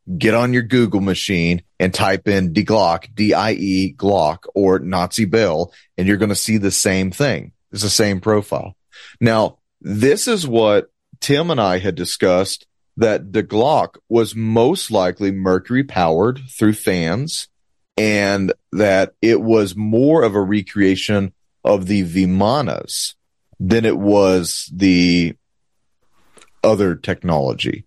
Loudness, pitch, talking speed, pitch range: -17 LUFS, 100 Hz, 140 wpm, 95-110 Hz